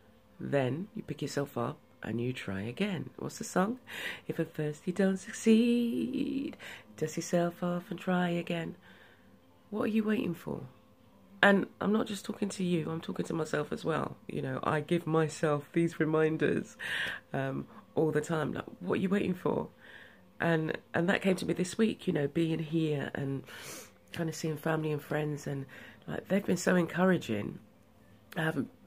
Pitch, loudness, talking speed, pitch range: 170 Hz, -32 LUFS, 180 wpm, 150-195 Hz